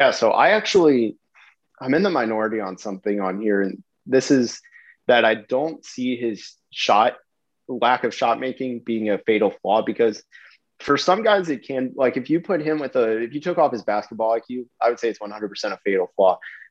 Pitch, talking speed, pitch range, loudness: 120 Hz, 205 wpm, 110-140 Hz, -21 LUFS